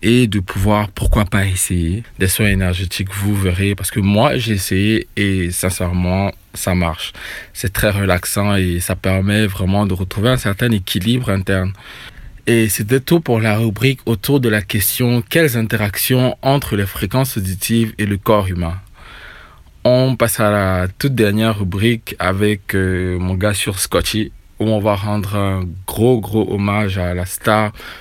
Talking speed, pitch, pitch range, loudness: 165 wpm, 105 Hz, 95-115 Hz, -17 LUFS